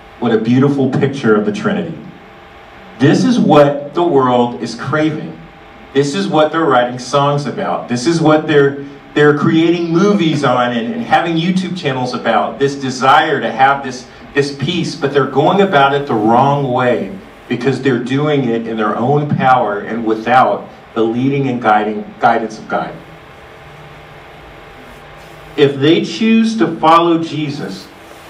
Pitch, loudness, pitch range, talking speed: 140 Hz, -13 LUFS, 125-155 Hz, 155 wpm